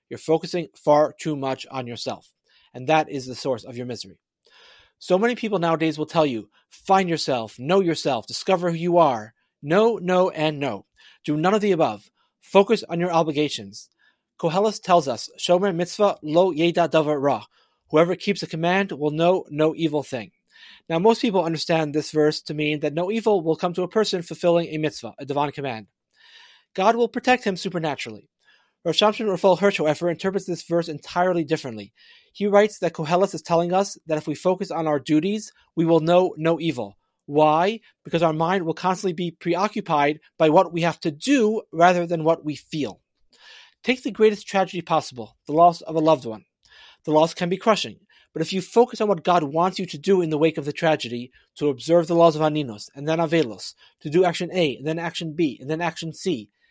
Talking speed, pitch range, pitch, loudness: 200 wpm, 150-185 Hz, 165 Hz, -22 LUFS